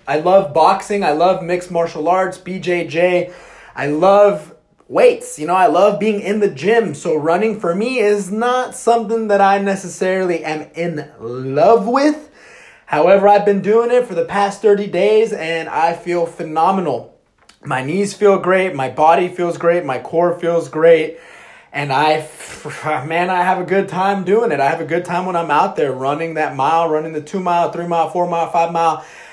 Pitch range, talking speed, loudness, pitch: 165-200 Hz, 190 wpm, -16 LUFS, 175 Hz